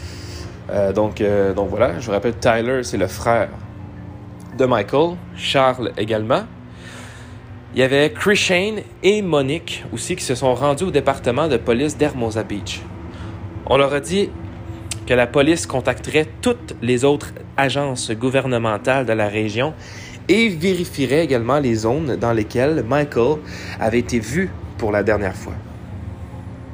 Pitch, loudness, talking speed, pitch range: 115 Hz, -19 LUFS, 145 wpm, 105-140 Hz